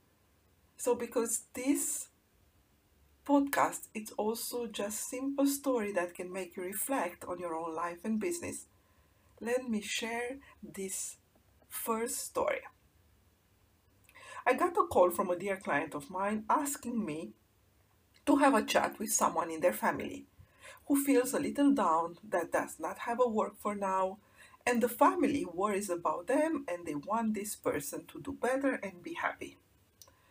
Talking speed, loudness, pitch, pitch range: 150 wpm, -33 LUFS, 205 Hz, 160-245 Hz